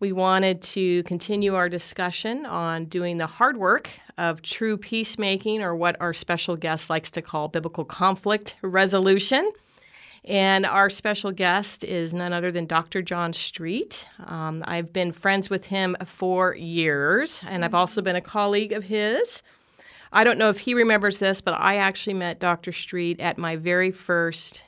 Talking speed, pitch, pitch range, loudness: 170 wpm, 185 Hz, 170-200 Hz, -23 LUFS